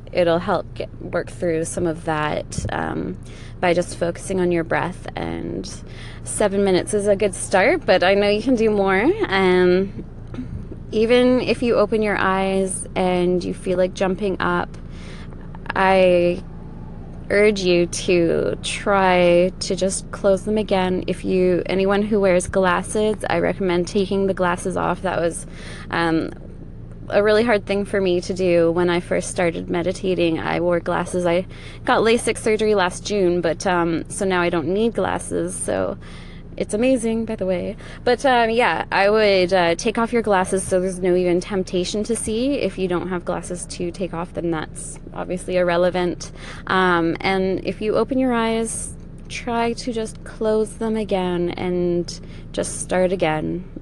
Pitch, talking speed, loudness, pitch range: 185 Hz, 165 wpm, -20 LUFS, 175-210 Hz